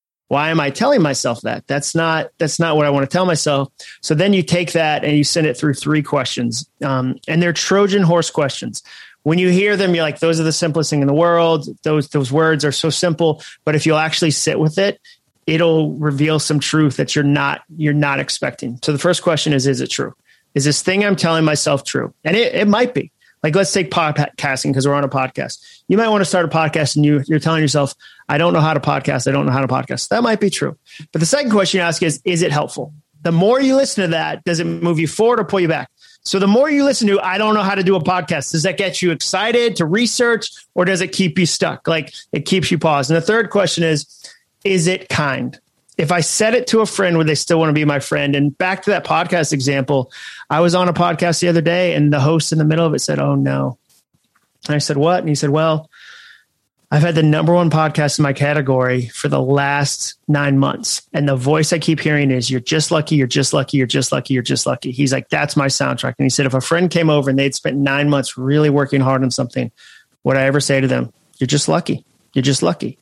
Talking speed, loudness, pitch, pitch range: 255 wpm, -16 LUFS, 155 Hz, 145-175 Hz